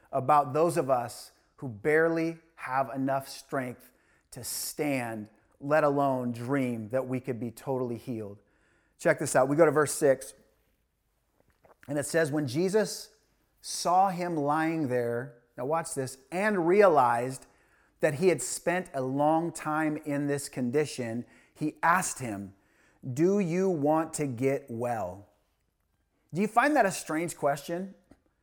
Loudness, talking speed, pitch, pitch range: -28 LUFS, 145 wpm, 140 Hz, 125-165 Hz